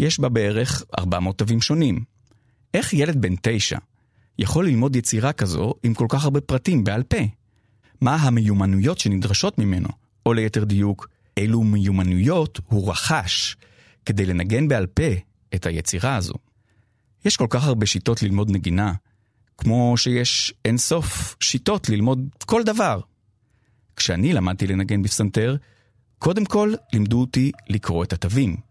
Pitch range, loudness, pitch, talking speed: 100-125 Hz, -21 LUFS, 110 Hz, 135 wpm